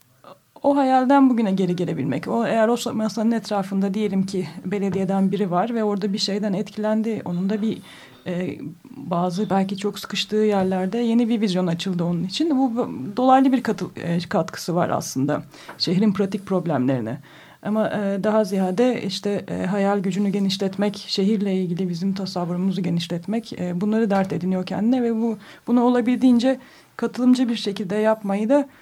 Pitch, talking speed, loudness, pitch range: 205 Hz, 155 wpm, -22 LUFS, 185-225 Hz